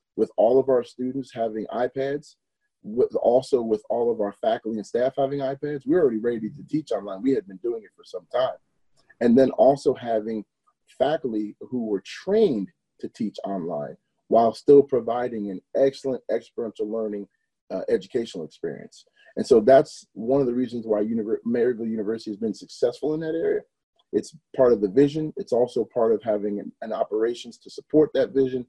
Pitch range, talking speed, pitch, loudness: 110-155 Hz, 185 wpm, 130 Hz, -24 LUFS